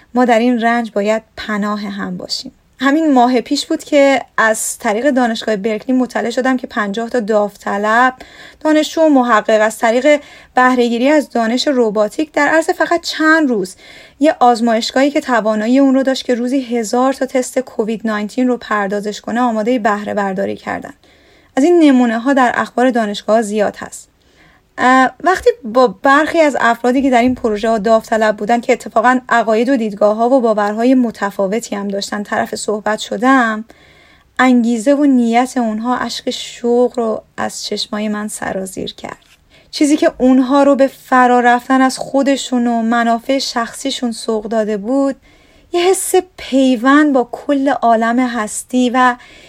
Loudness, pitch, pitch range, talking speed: -14 LUFS, 245 Hz, 225-270 Hz, 160 wpm